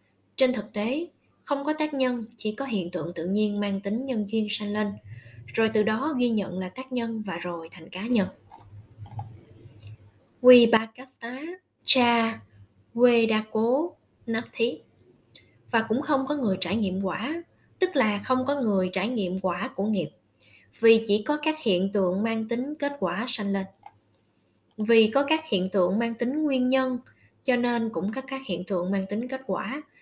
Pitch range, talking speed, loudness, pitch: 180-250 Hz, 180 wpm, -26 LUFS, 215 Hz